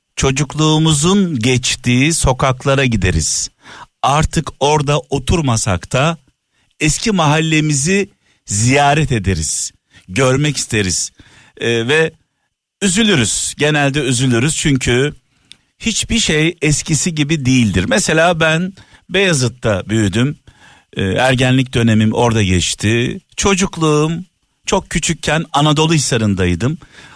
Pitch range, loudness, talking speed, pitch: 120-160 Hz, -14 LUFS, 85 wpm, 140 Hz